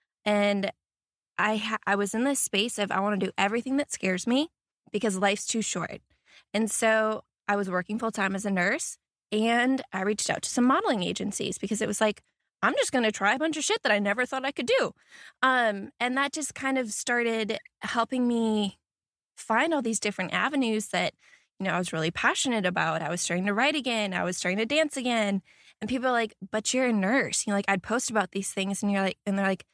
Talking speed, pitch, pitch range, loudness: 230 wpm, 220 Hz, 200-250 Hz, -27 LUFS